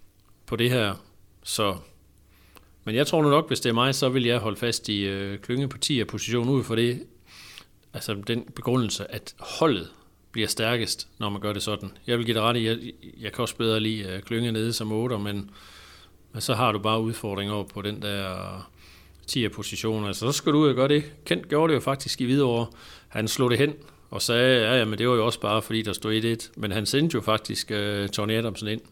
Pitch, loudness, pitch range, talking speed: 110 Hz, -25 LUFS, 100-120 Hz, 230 wpm